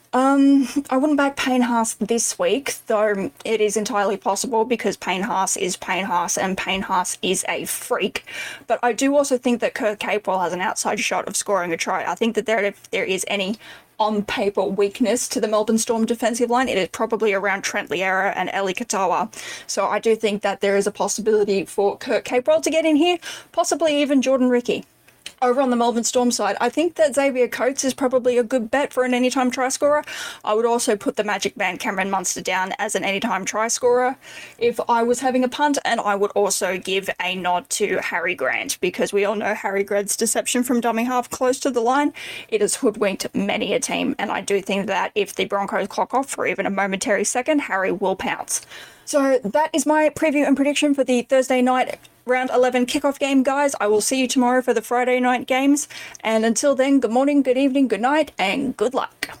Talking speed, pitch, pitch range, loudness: 215 wpm, 235 Hz, 205-265 Hz, -20 LUFS